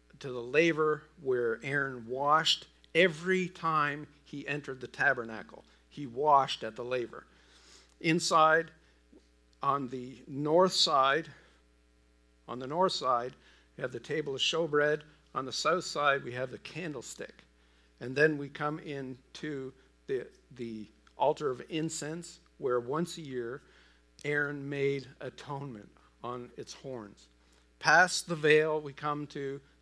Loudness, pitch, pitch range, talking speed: -31 LUFS, 140 Hz, 120-155 Hz, 135 wpm